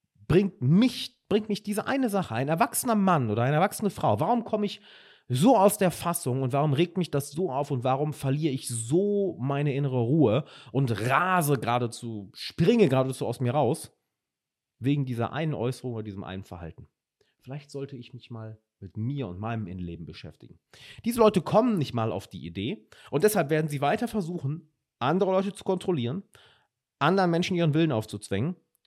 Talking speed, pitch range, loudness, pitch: 180 wpm, 120-185 Hz, -26 LUFS, 145 Hz